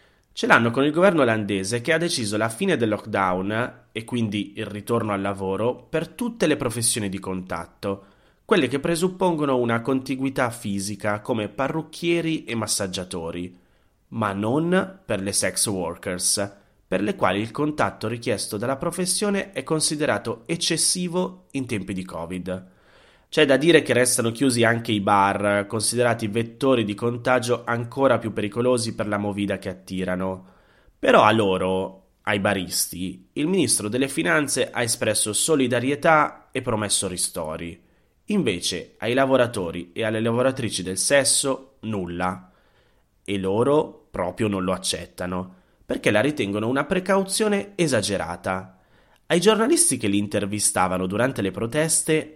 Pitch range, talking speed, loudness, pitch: 100-135 Hz, 140 wpm, -23 LUFS, 110 Hz